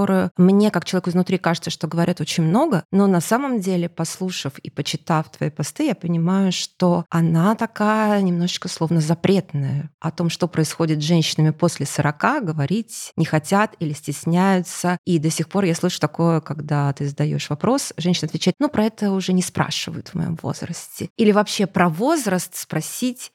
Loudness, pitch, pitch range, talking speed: -21 LUFS, 175 Hz, 160-190 Hz, 170 wpm